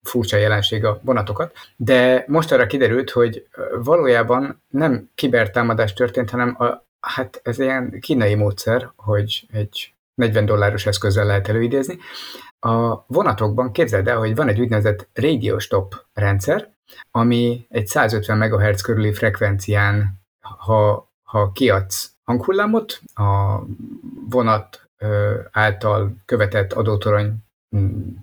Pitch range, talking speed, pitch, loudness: 105-125 Hz, 115 wpm, 110 Hz, -19 LUFS